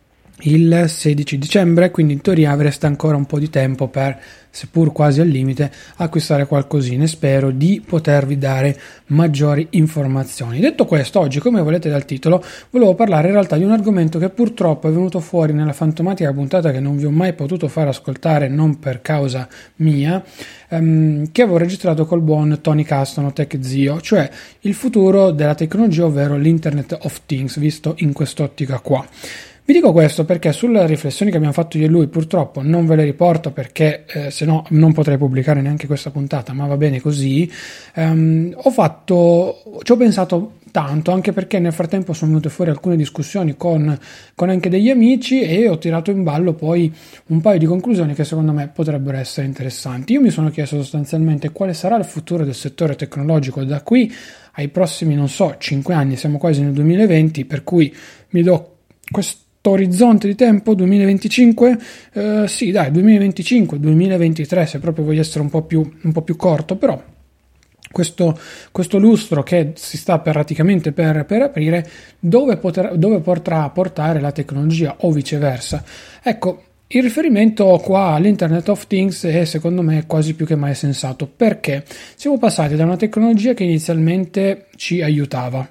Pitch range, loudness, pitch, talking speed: 145-185 Hz, -16 LUFS, 160 Hz, 170 wpm